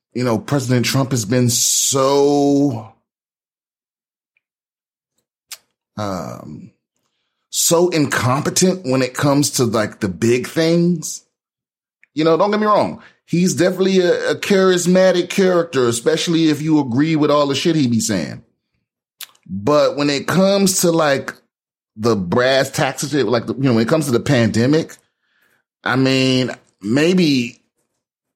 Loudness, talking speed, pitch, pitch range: -16 LUFS, 130 wpm, 145 Hz, 125-170 Hz